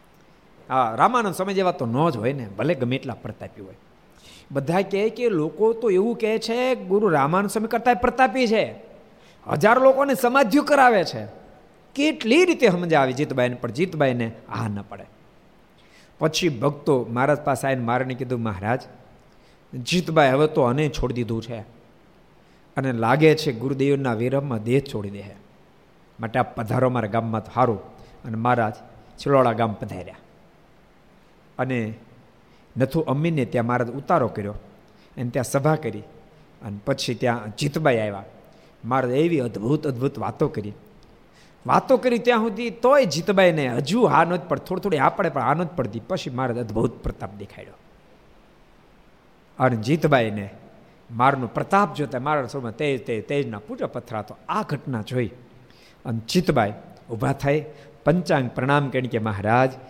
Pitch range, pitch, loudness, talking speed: 120-170 Hz, 135 Hz, -22 LUFS, 145 wpm